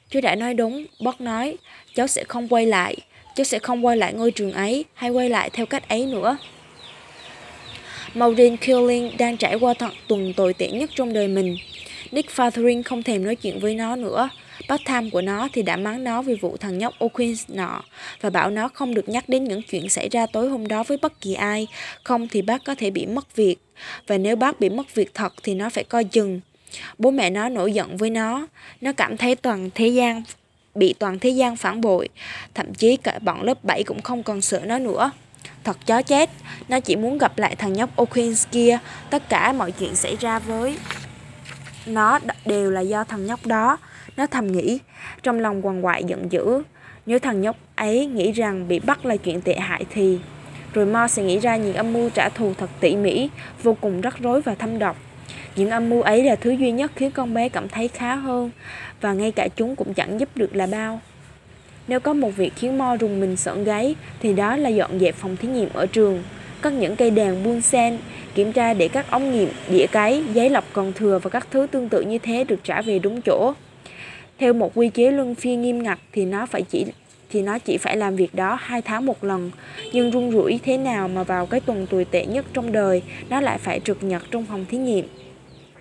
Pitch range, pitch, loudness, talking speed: 195-245 Hz, 225 Hz, -22 LUFS, 225 wpm